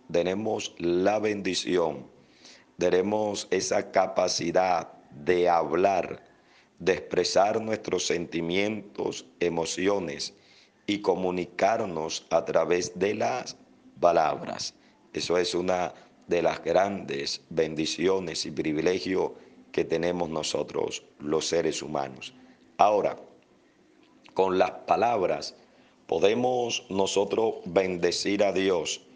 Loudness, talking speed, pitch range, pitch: -27 LUFS, 90 wpm, 80-100 Hz, 90 Hz